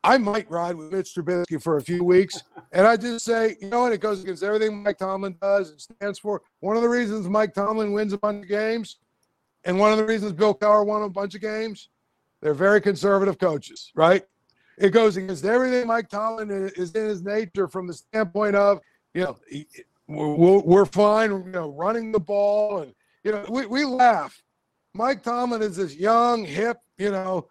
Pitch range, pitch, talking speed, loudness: 190-220 Hz, 205 Hz, 200 wpm, -23 LUFS